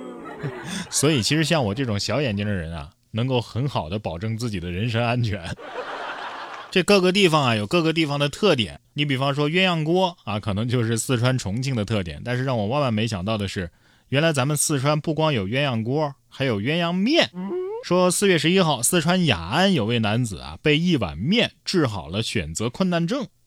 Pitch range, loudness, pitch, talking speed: 110-165 Hz, -22 LUFS, 130 Hz, 295 characters per minute